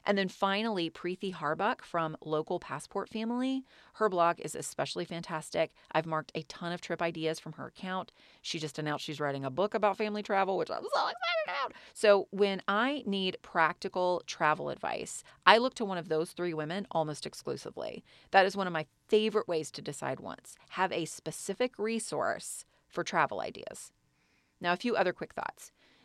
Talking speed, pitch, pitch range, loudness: 180 wpm, 180 Hz, 160-205 Hz, -32 LUFS